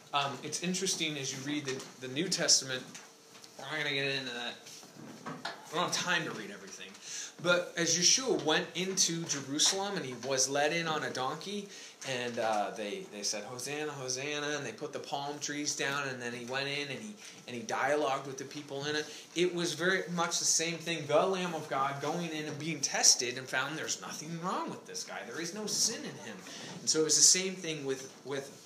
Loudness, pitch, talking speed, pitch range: -32 LUFS, 150 Hz, 220 wpm, 140-170 Hz